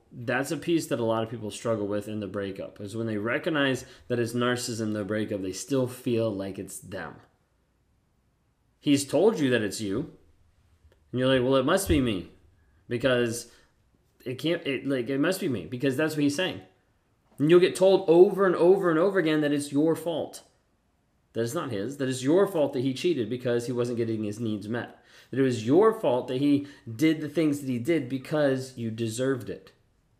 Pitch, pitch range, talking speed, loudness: 125 Hz, 110-145 Hz, 210 wpm, -26 LUFS